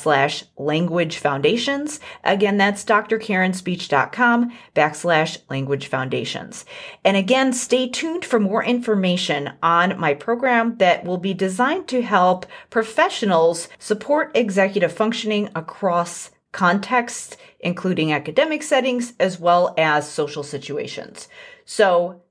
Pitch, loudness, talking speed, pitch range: 195 Hz, -20 LUFS, 105 wpm, 170-240 Hz